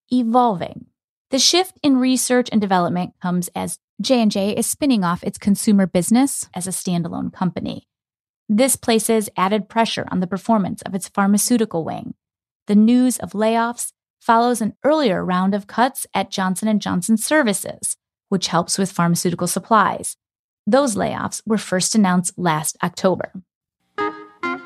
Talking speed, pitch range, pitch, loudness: 140 wpm, 180-235 Hz, 210 Hz, -19 LUFS